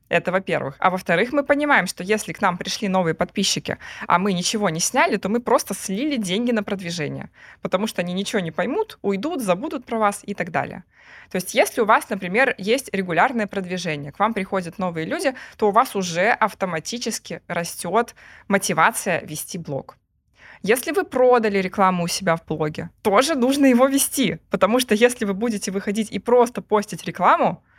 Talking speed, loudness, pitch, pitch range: 180 wpm, -21 LUFS, 200 Hz, 180-235 Hz